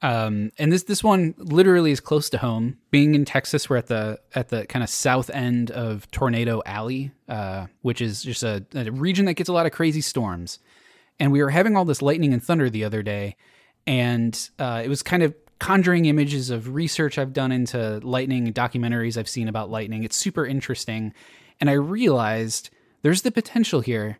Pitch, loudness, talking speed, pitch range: 130 Hz, -23 LUFS, 200 wpm, 115-150 Hz